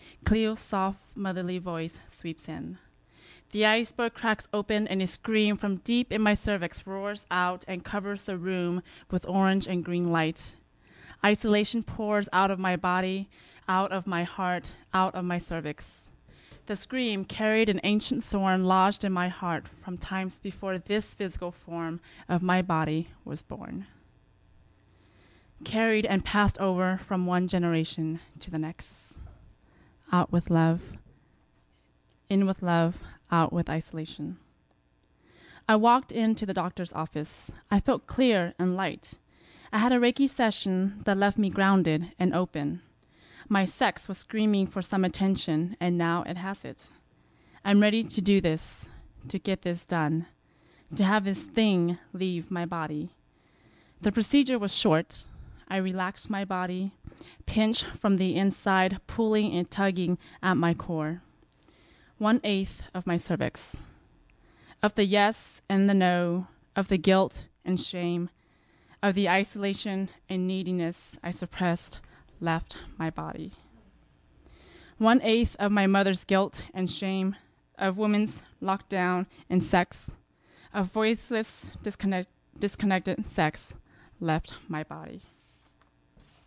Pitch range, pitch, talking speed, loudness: 170-205 Hz, 185 Hz, 135 wpm, -28 LUFS